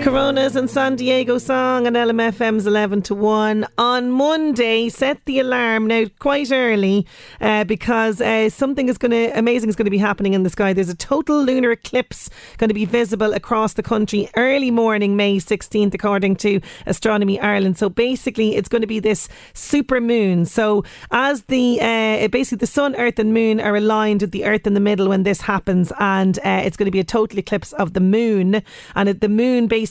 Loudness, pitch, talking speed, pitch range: -18 LUFS, 220 Hz, 200 wpm, 205-245 Hz